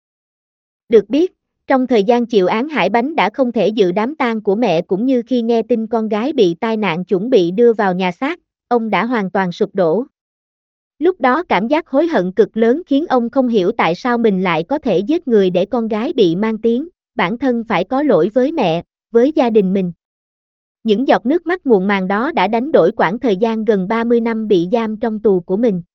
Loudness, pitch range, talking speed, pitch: -15 LUFS, 200-255 Hz, 225 wpm, 230 Hz